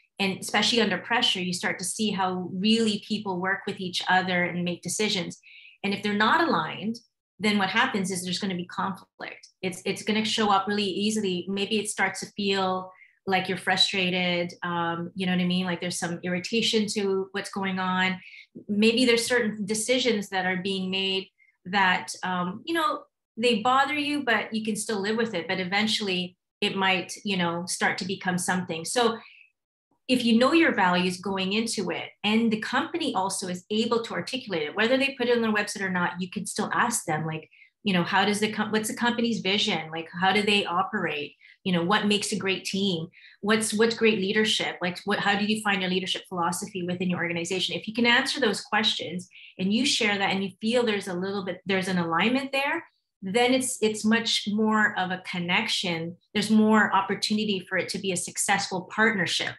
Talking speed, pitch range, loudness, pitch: 205 wpm, 185-220 Hz, -25 LUFS, 195 Hz